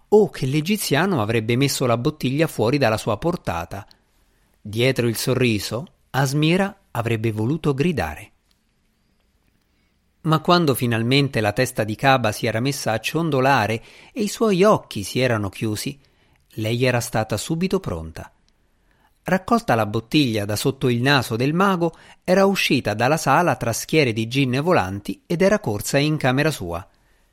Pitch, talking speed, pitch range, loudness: 130 Hz, 150 wpm, 110-155 Hz, -21 LUFS